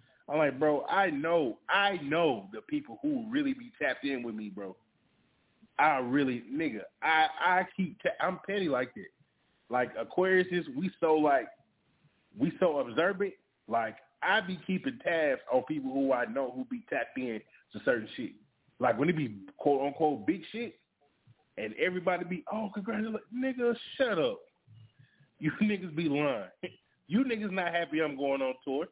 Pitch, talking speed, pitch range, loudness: 175 Hz, 170 wpm, 140-220 Hz, -31 LUFS